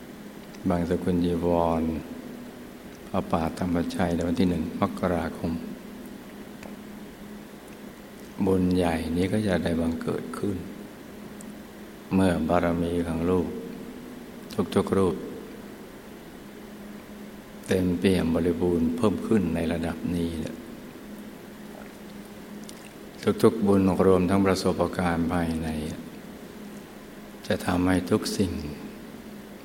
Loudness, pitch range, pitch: -26 LUFS, 85-90 Hz, 85 Hz